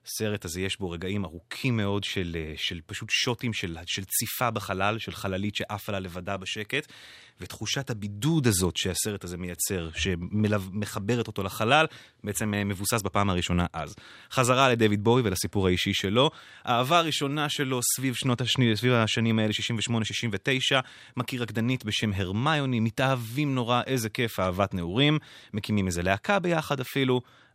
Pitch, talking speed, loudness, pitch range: 110 Hz, 145 wpm, -27 LUFS, 100-125 Hz